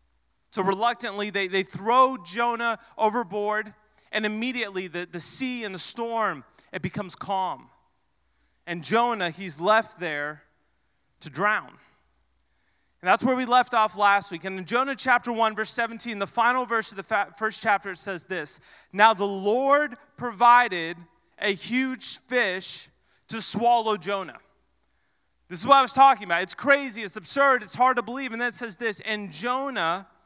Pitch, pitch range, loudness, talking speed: 215 Hz, 180-240 Hz, -24 LUFS, 165 wpm